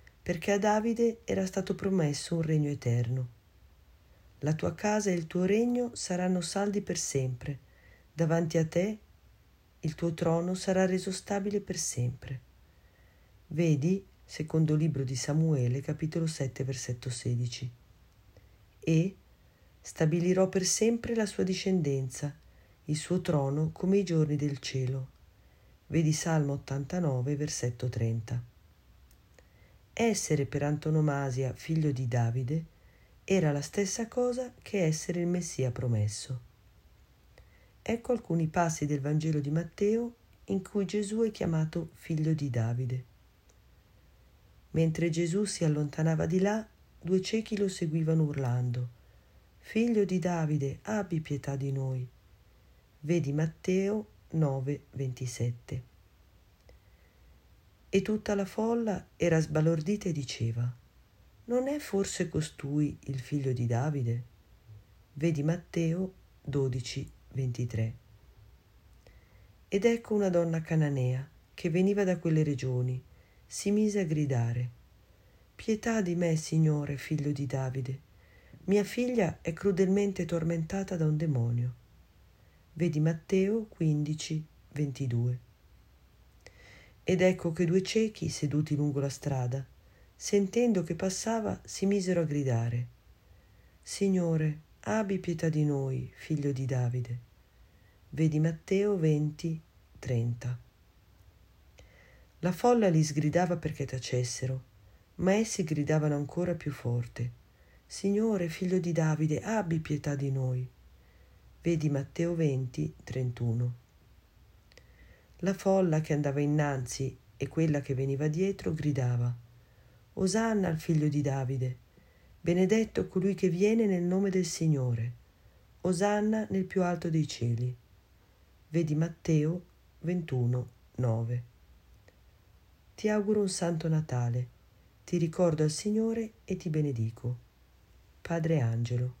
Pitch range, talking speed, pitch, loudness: 120-180 Hz, 115 wpm, 150 Hz, -31 LUFS